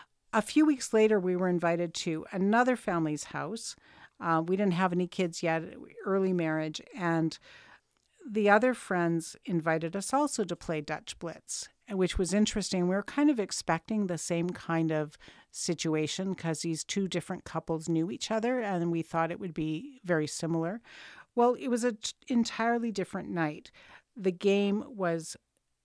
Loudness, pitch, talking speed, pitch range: -31 LUFS, 185 Hz, 165 wpm, 165-215 Hz